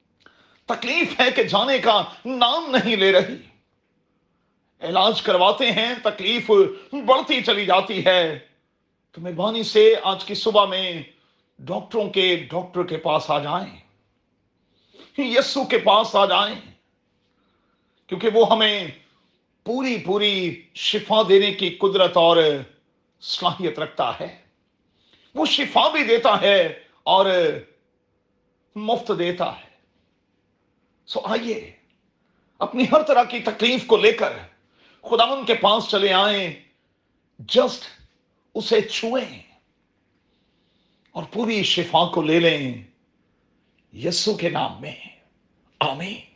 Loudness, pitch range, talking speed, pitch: -20 LUFS, 180-235 Hz, 115 wpm, 210 Hz